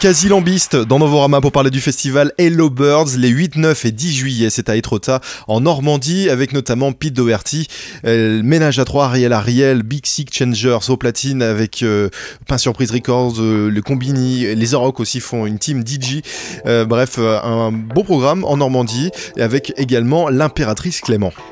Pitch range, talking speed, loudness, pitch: 115-145 Hz, 180 wpm, -15 LUFS, 130 Hz